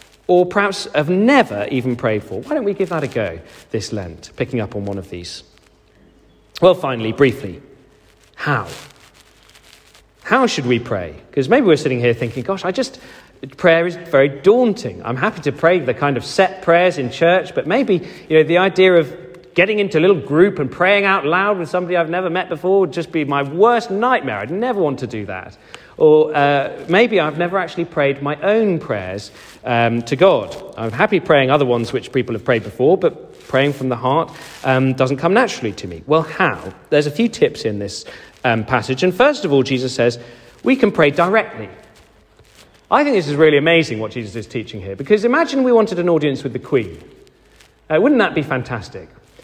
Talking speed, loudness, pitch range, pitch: 205 wpm, -16 LUFS, 120-185 Hz, 155 Hz